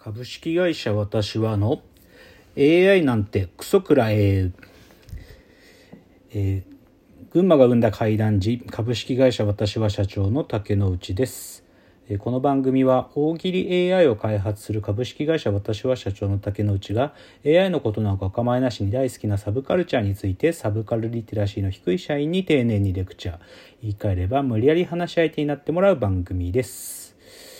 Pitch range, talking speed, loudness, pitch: 100-130 Hz, 325 characters per minute, -22 LUFS, 110 Hz